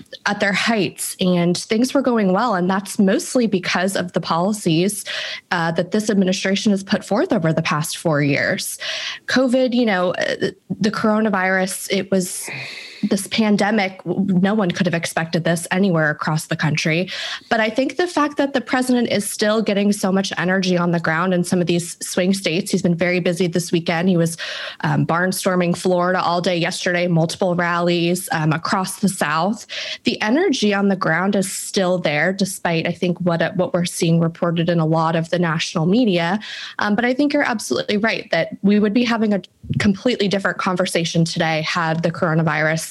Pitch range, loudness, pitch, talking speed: 175-205 Hz, -19 LUFS, 185 Hz, 185 wpm